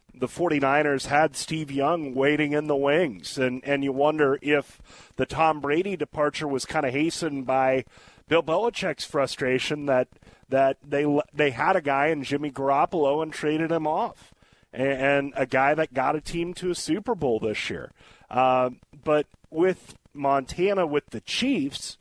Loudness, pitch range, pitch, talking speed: -25 LUFS, 135-155 Hz, 145 Hz, 165 wpm